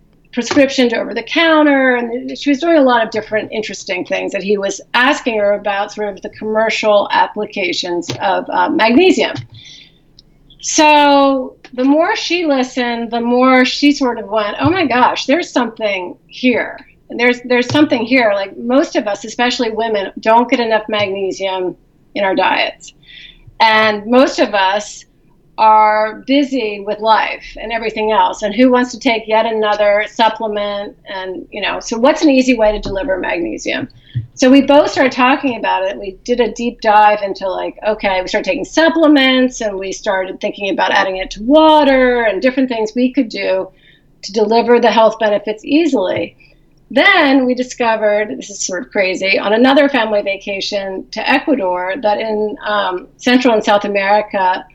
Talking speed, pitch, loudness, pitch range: 170 wpm, 225 Hz, -14 LUFS, 205-265 Hz